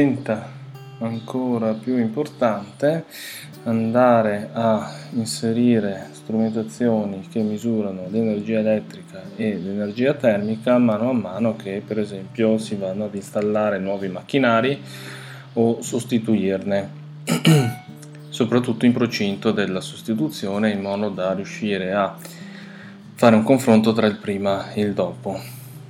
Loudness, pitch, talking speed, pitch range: -21 LUFS, 110 Hz, 110 wpm, 105-125 Hz